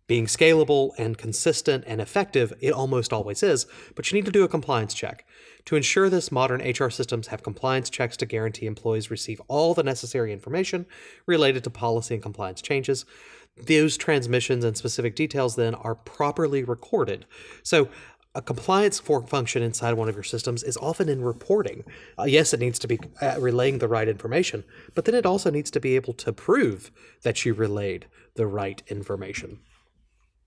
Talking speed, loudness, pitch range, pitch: 180 wpm, -25 LUFS, 115-150 Hz, 125 Hz